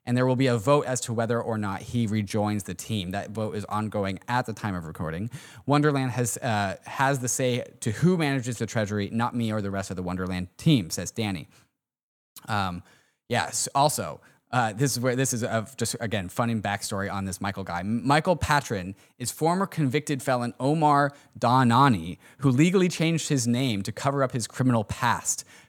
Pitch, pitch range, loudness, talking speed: 120 Hz, 105-135 Hz, -26 LUFS, 200 wpm